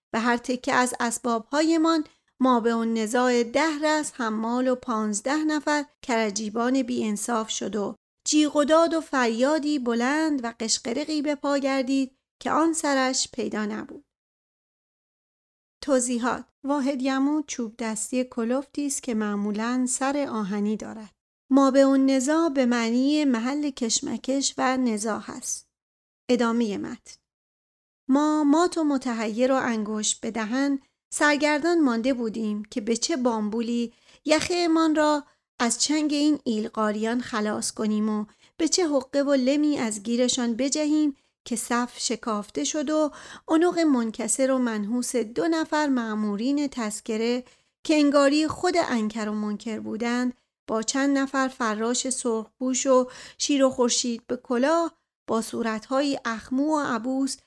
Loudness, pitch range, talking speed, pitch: -25 LUFS, 230-290 Hz, 135 wpm, 255 Hz